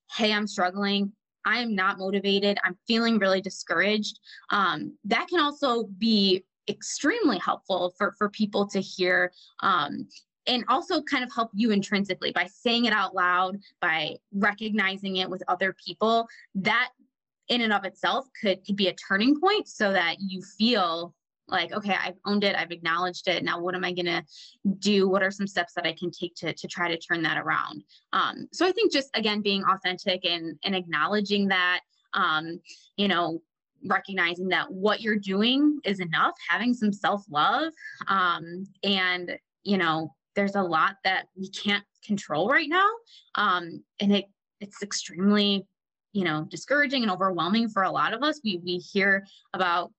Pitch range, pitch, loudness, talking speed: 180-215 Hz, 195 Hz, -26 LUFS, 175 wpm